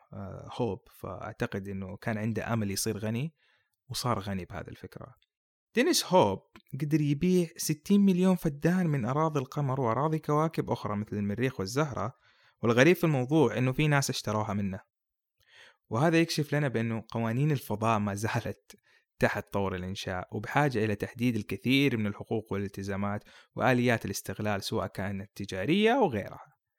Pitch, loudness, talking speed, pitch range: 115 Hz, -29 LUFS, 135 wpm, 100-145 Hz